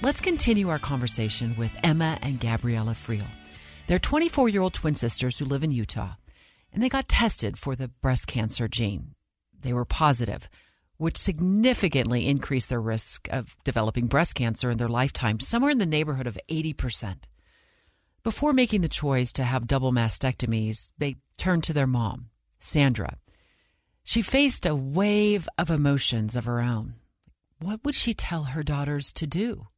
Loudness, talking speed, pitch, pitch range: -25 LUFS, 160 wpm, 130 Hz, 115-170 Hz